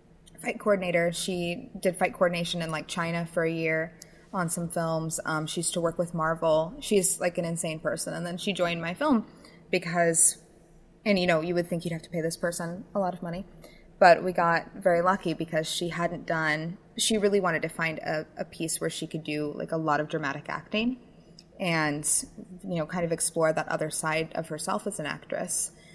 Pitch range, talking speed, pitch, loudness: 160-180 Hz, 210 wpm, 170 Hz, -28 LUFS